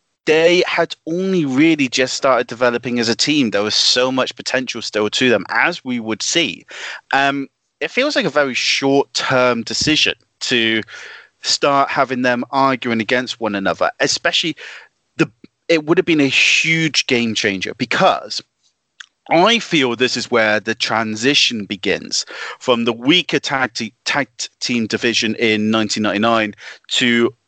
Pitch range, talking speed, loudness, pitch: 115-150 Hz, 150 wpm, -16 LUFS, 125 Hz